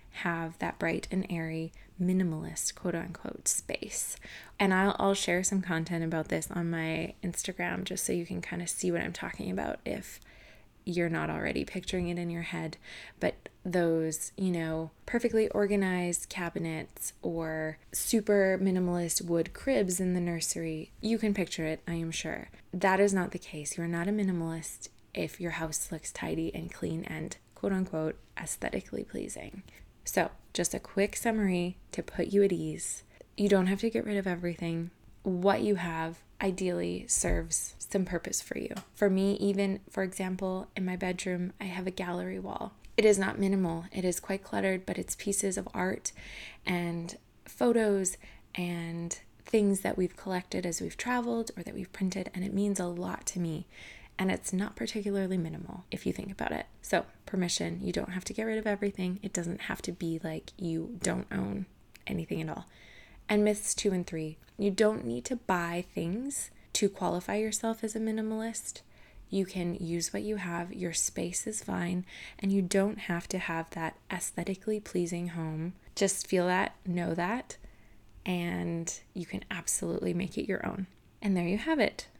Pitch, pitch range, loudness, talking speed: 180 Hz, 165-195 Hz, -32 LUFS, 180 wpm